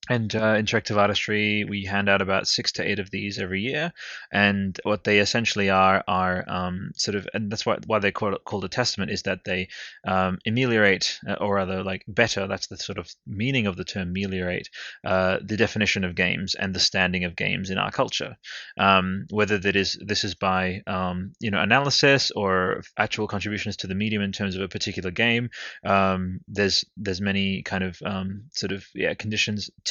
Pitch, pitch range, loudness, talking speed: 100 Hz, 95-105 Hz, -24 LUFS, 200 wpm